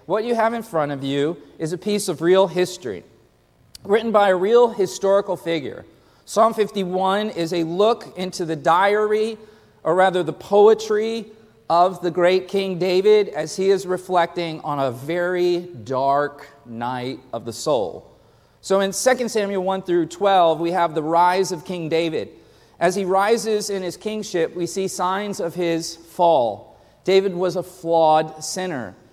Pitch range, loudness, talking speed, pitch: 165-200 Hz, -20 LUFS, 165 wpm, 180 Hz